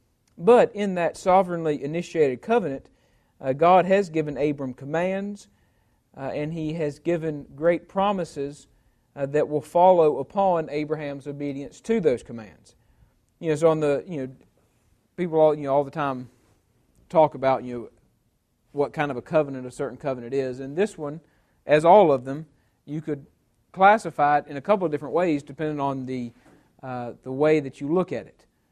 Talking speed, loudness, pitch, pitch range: 175 wpm, -23 LUFS, 145 Hz, 135-165 Hz